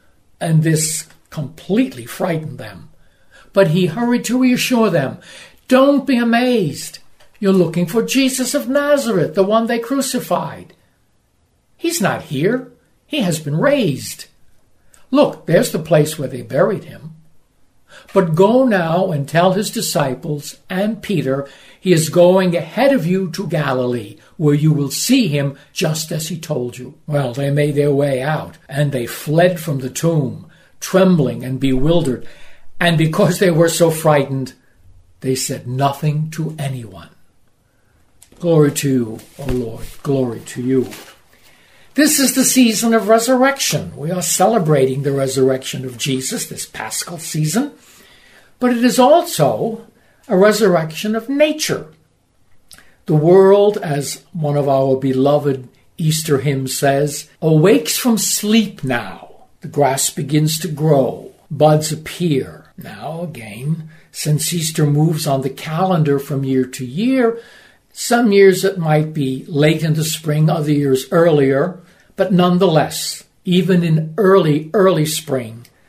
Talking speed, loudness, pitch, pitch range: 140 wpm, -16 LUFS, 160 Hz, 140-195 Hz